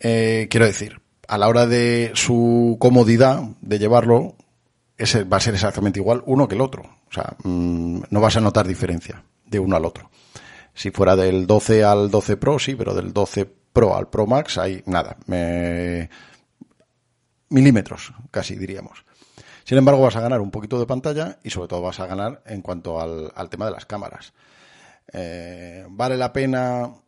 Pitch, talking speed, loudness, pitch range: 110 Hz, 180 wpm, -19 LUFS, 95-120 Hz